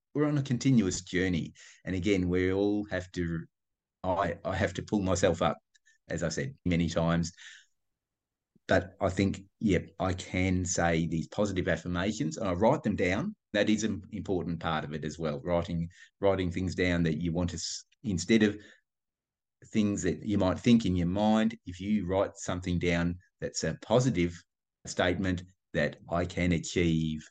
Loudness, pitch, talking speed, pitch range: -30 LUFS, 90 Hz, 175 wpm, 85-105 Hz